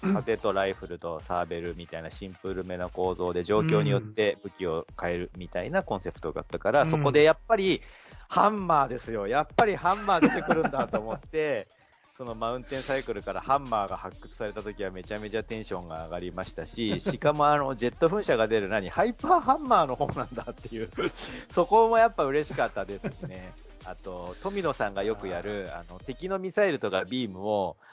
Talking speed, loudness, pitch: 430 characters per minute, -28 LUFS, 110 Hz